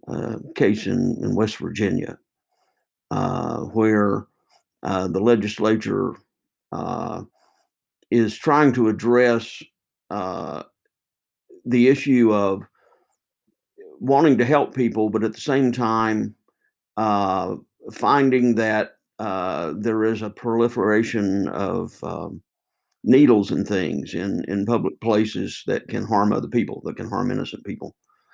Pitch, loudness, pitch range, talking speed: 110 Hz, -21 LUFS, 105-120 Hz, 120 wpm